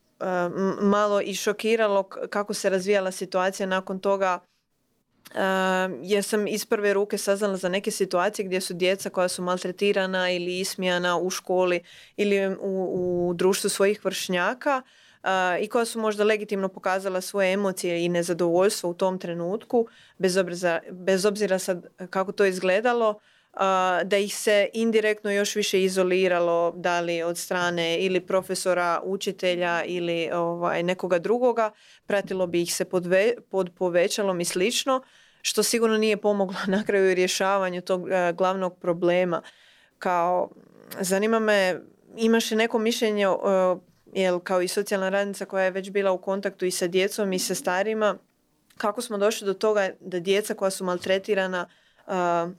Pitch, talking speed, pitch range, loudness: 190 Hz, 145 wpm, 180-205 Hz, -25 LUFS